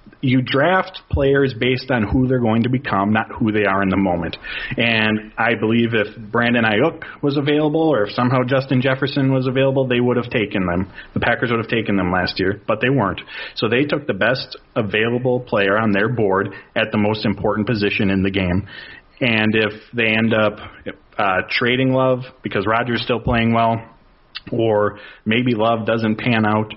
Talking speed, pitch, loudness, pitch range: 195 wpm, 115 Hz, -18 LUFS, 105-130 Hz